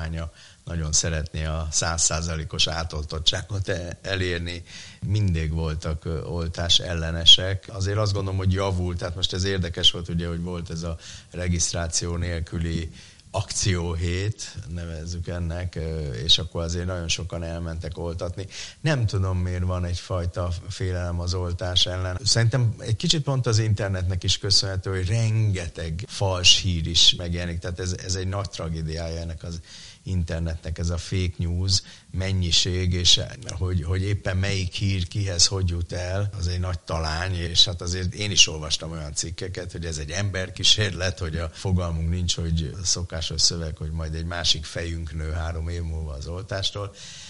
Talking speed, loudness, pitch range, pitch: 150 wpm, -24 LUFS, 85-95 Hz, 90 Hz